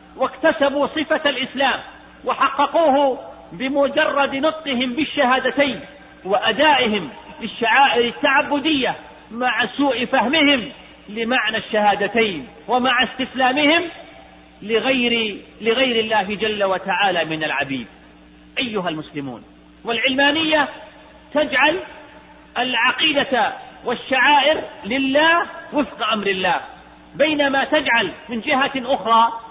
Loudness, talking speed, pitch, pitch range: -18 LUFS, 80 wpm, 260 Hz, 225-290 Hz